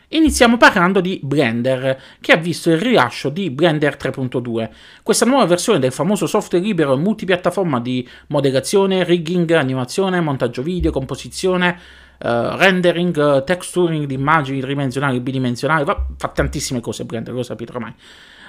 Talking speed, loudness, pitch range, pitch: 145 wpm, -17 LUFS, 130-180 Hz, 150 Hz